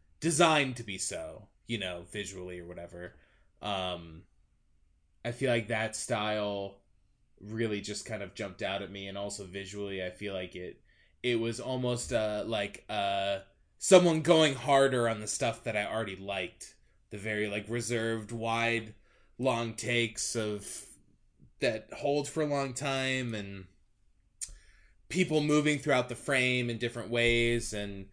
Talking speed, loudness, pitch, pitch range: 150 wpm, -31 LUFS, 110 Hz, 100-120 Hz